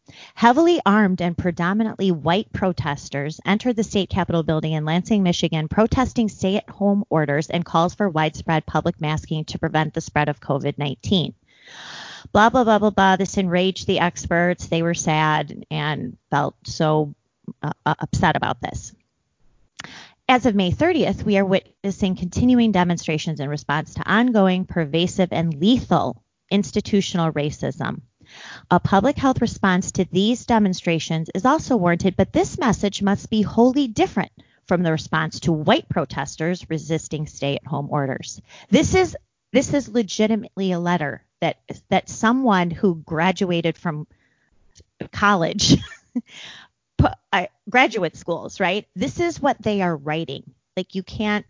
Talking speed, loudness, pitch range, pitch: 140 wpm, -21 LUFS, 160-210 Hz, 180 Hz